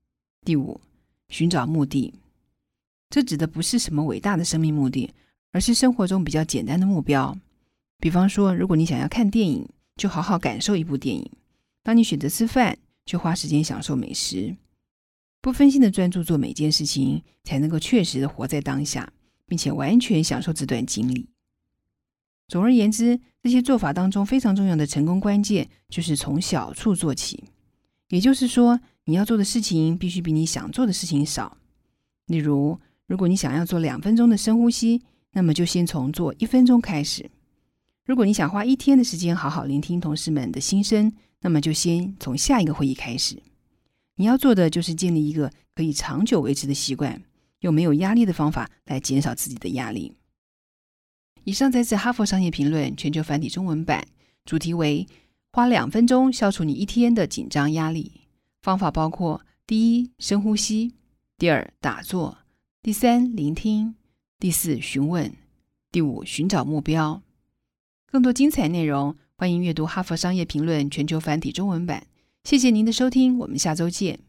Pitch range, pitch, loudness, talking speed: 150-220 Hz, 170 Hz, -22 LUFS, 265 characters per minute